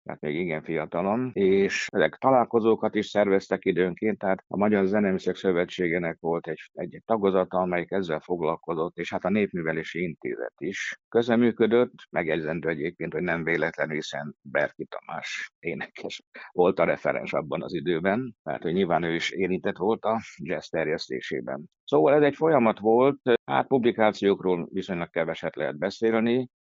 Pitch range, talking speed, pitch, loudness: 95-115 Hz, 150 wpm, 105 Hz, -26 LUFS